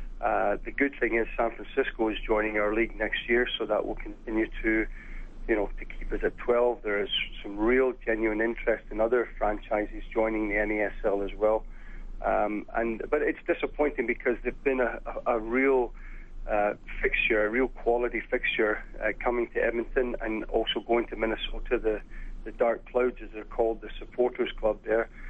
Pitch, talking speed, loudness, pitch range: 110 Hz, 185 wpm, -28 LUFS, 105-120 Hz